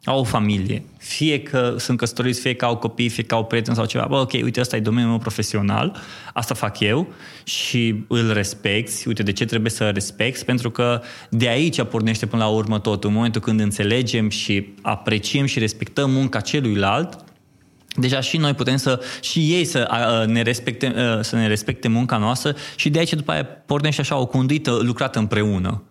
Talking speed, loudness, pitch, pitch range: 190 wpm, -21 LUFS, 120 Hz, 110-130 Hz